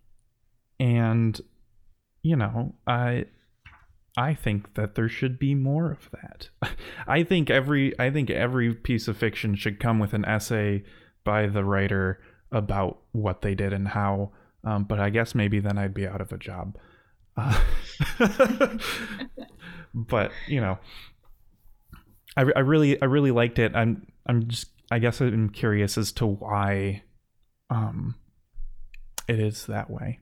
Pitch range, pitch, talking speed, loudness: 100-125 Hz, 110 Hz, 145 wpm, -26 LUFS